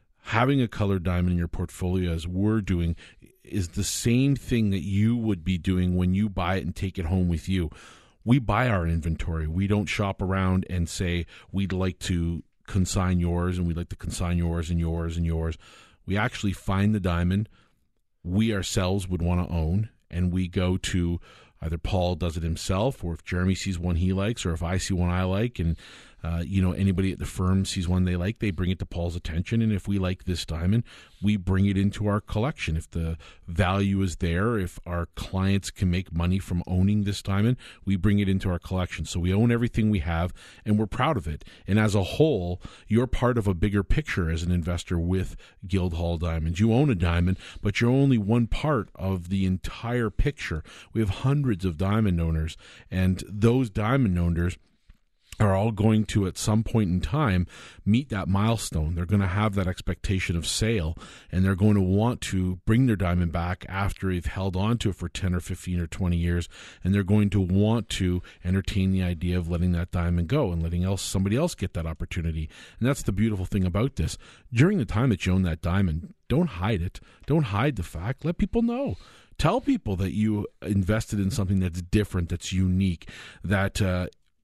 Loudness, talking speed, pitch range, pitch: -26 LUFS, 210 wpm, 90-105 Hz, 95 Hz